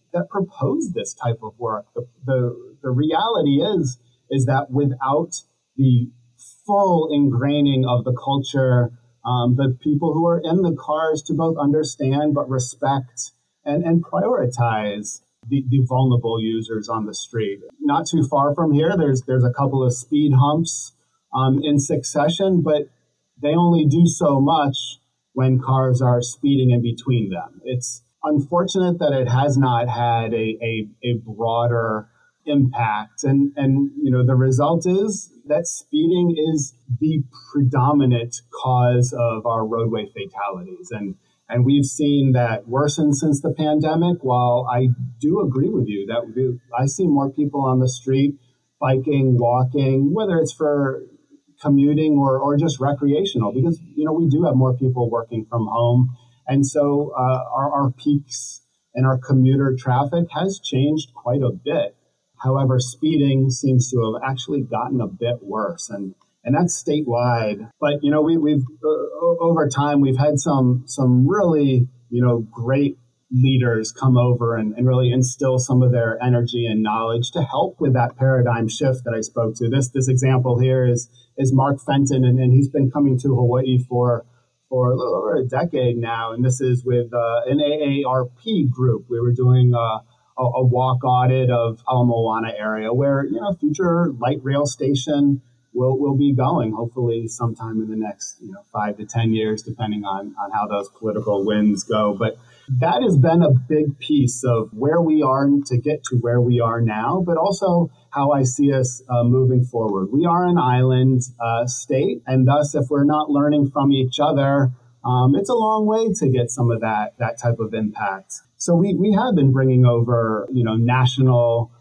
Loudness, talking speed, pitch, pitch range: -19 LUFS, 175 wpm, 130 Hz, 120-145 Hz